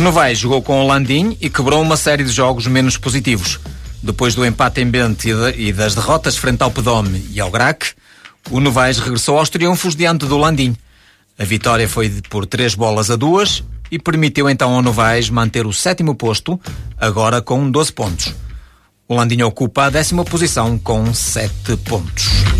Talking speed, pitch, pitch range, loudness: 175 wpm, 125 Hz, 110-140 Hz, -15 LUFS